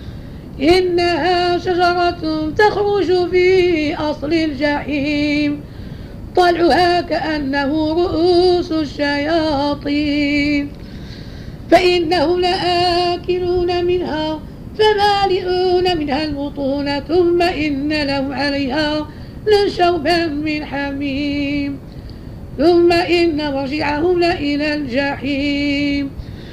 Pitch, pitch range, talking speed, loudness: 320 Hz, 290-355 Hz, 65 wpm, -16 LUFS